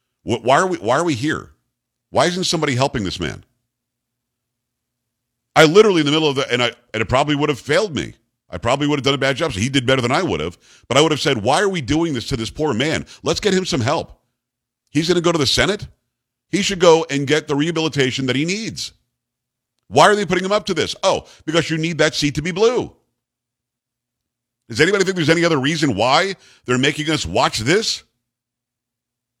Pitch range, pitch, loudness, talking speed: 120-160 Hz, 135 Hz, -18 LUFS, 225 wpm